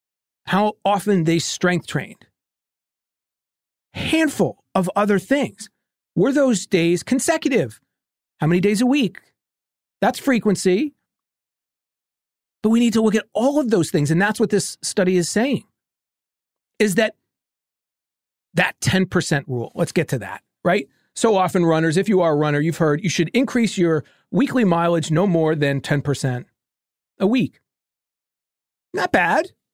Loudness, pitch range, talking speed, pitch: -20 LUFS, 165-220 Hz, 145 wpm, 185 Hz